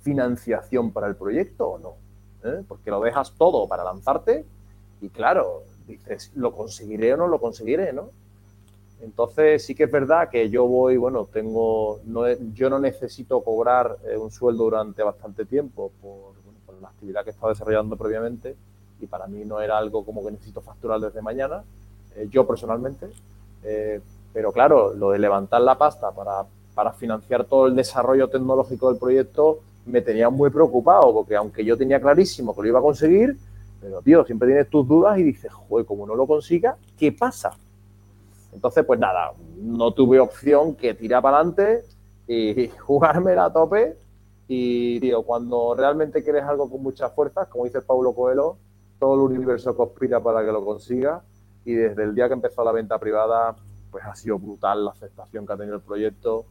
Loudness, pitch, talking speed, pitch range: -21 LUFS, 115 Hz, 180 wpm, 100-130 Hz